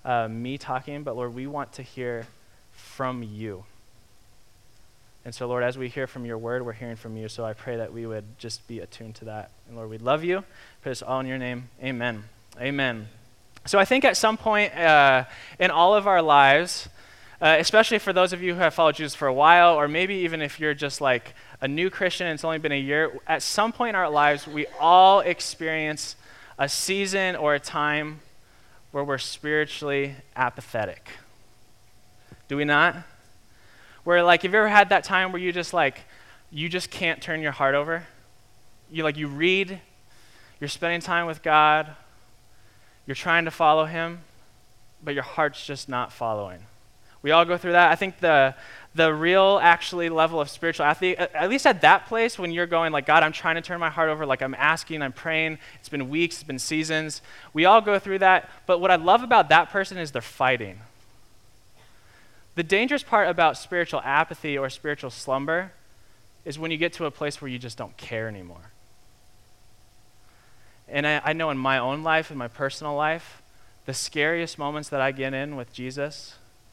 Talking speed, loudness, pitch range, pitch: 195 wpm, -23 LUFS, 120-165 Hz, 145 Hz